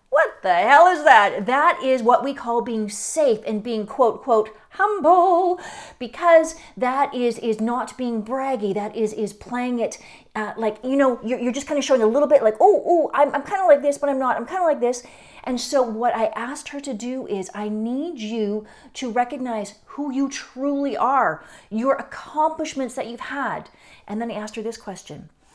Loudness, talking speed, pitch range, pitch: -21 LUFS, 210 wpm, 220-285 Hz, 250 Hz